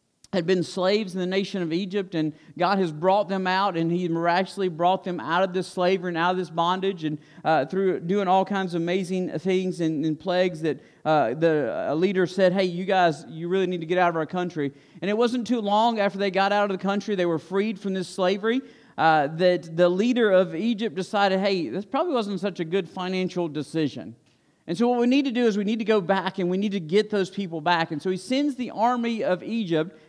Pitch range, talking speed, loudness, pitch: 170-200 Hz, 240 wpm, -24 LUFS, 185 Hz